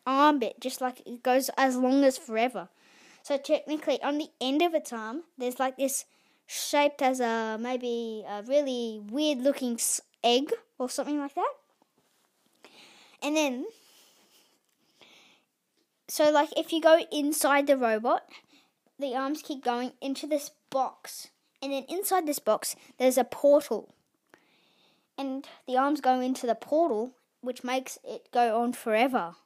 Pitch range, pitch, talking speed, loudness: 245-295 Hz, 270 Hz, 145 wpm, -28 LUFS